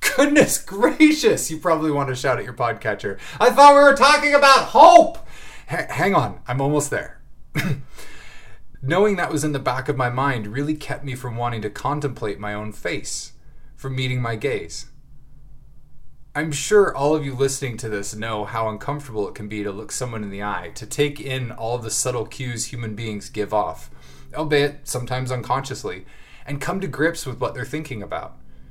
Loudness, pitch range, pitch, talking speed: -20 LUFS, 110-150 Hz, 130 Hz, 185 wpm